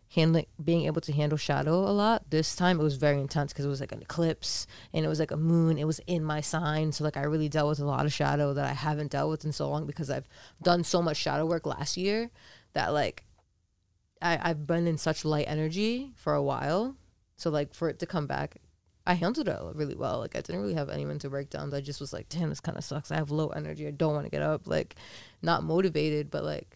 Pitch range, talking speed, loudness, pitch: 140-165 Hz, 255 wpm, -30 LUFS, 150 Hz